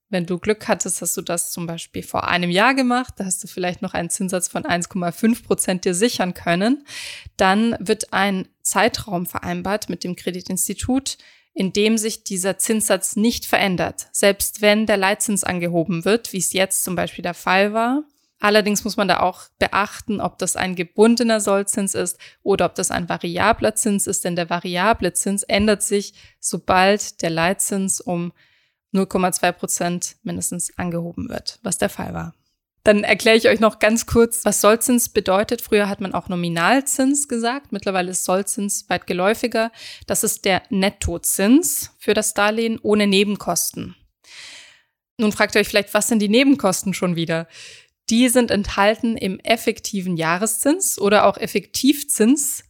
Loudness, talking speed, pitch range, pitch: -19 LUFS, 165 wpm, 185-225 Hz, 200 Hz